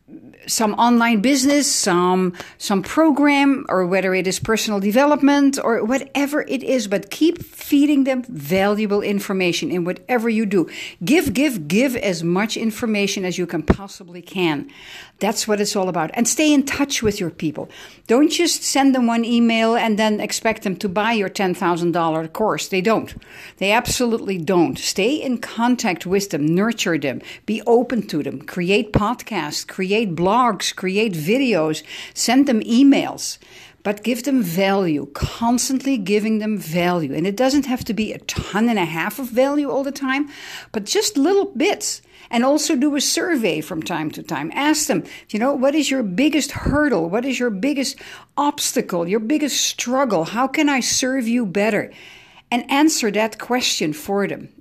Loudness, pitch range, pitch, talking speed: -19 LUFS, 190-270 Hz, 225 Hz, 175 wpm